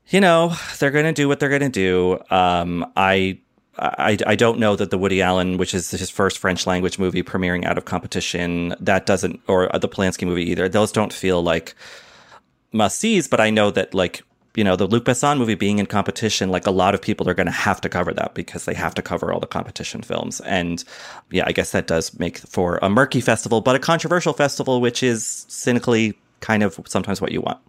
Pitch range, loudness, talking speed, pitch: 90-125 Hz, -20 LUFS, 225 wpm, 105 Hz